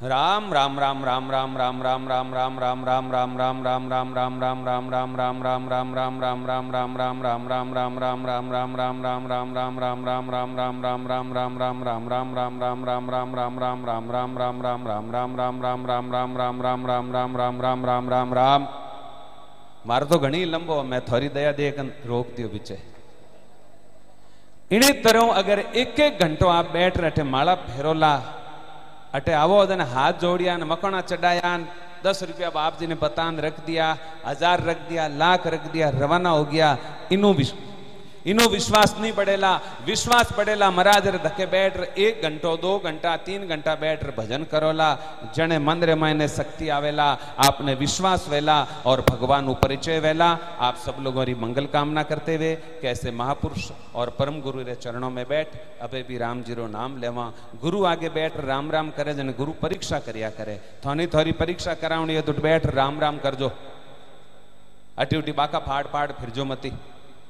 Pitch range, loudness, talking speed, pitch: 125-160 Hz, -23 LUFS, 160 wpm, 140 Hz